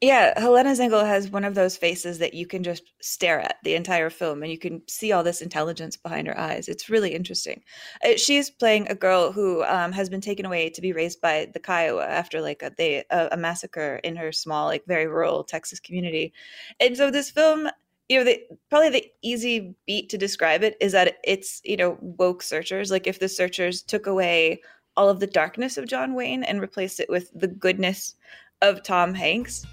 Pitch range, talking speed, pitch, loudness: 170-210 Hz, 210 wpm, 185 Hz, -23 LUFS